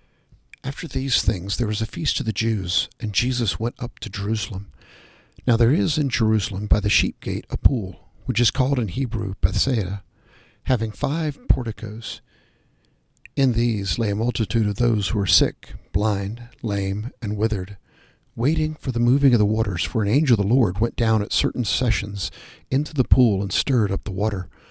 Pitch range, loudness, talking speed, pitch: 105-125 Hz, -22 LUFS, 185 wpm, 115 Hz